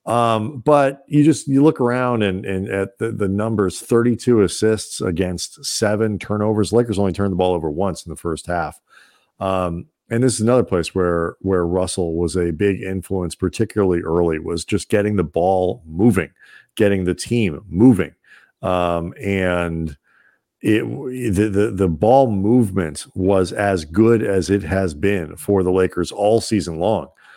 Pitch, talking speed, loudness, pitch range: 100 Hz, 165 wpm, -19 LUFS, 90-110 Hz